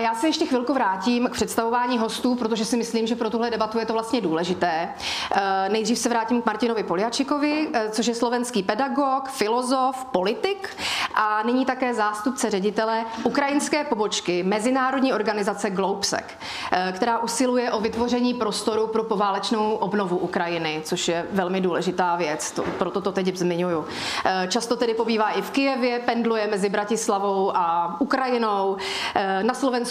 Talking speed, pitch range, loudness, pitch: 145 wpm, 200-245 Hz, -23 LUFS, 225 Hz